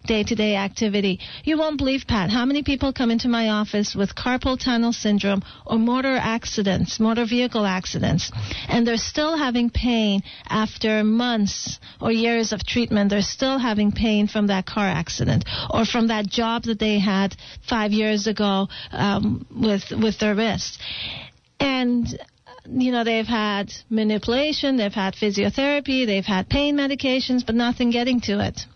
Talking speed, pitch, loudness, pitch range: 160 wpm, 225 Hz, -22 LUFS, 205-245 Hz